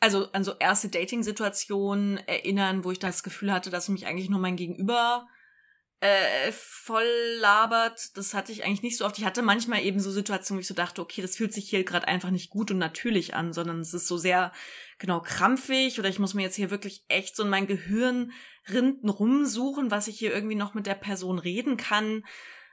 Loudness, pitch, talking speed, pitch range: -27 LUFS, 200 Hz, 210 wpm, 190-225 Hz